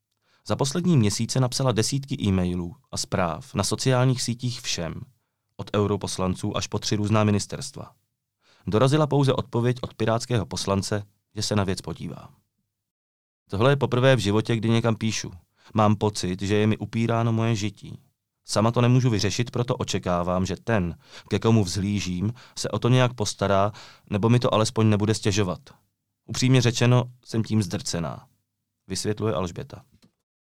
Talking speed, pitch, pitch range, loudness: 145 wpm, 110 Hz, 100-120 Hz, -24 LUFS